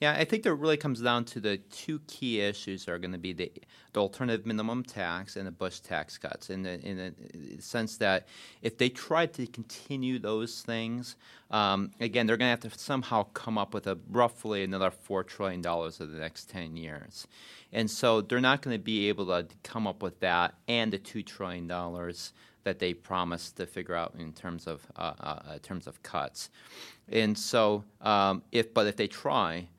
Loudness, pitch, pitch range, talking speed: -32 LUFS, 105 Hz, 90-120 Hz, 210 wpm